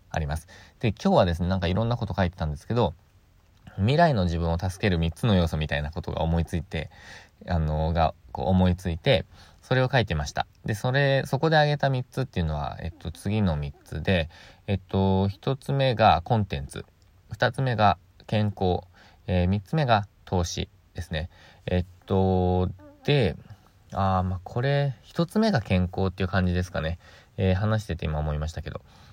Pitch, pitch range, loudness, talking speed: 95 Hz, 85-110 Hz, -26 LUFS, 350 characters per minute